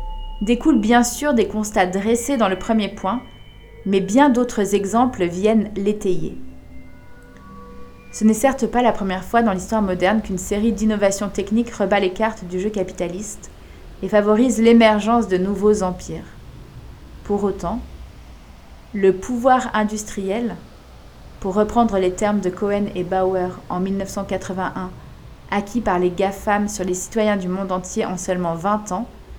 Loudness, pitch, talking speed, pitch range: -20 LUFS, 205 Hz, 145 wpm, 185-220 Hz